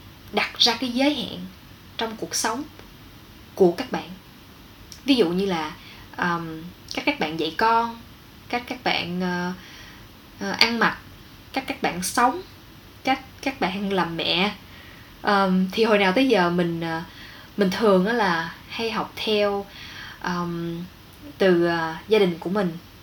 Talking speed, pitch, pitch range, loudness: 150 wpm, 185 Hz, 165-225 Hz, -23 LUFS